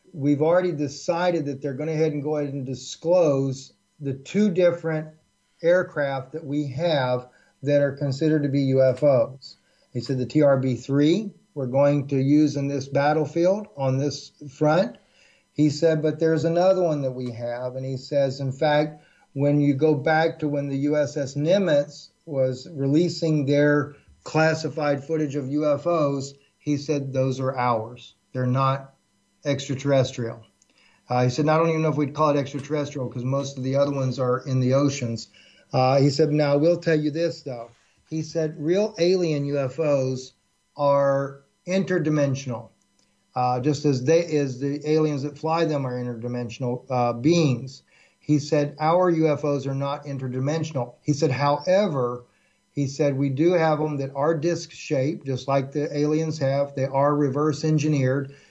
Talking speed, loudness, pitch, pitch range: 170 wpm, -23 LUFS, 145 Hz, 135-155 Hz